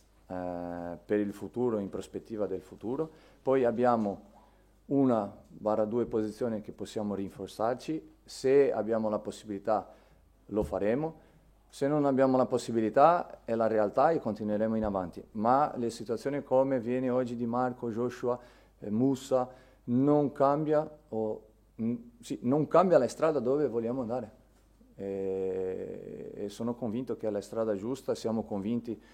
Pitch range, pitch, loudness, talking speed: 105-130 Hz, 115 Hz, -31 LUFS, 140 wpm